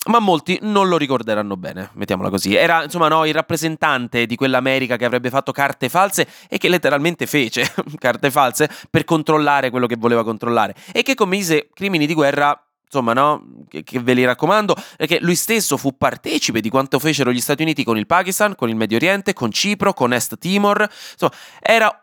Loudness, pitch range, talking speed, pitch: -17 LUFS, 125-175 Hz, 190 wpm, 145 Hz